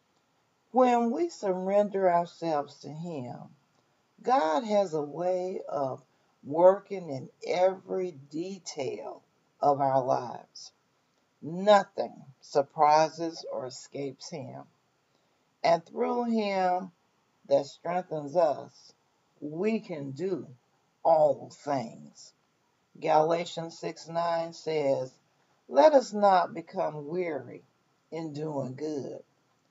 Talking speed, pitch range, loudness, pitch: 90 wpm, 150-190 Hz, -28 LUFS, 165 Hz